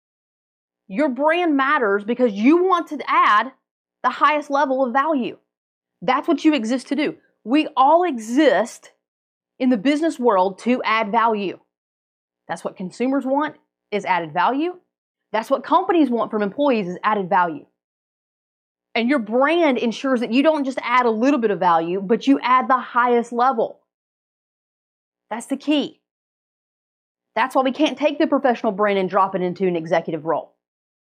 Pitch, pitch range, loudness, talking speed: 240 Hz, 185-285 Hz, -19 LUFS, 160 wpm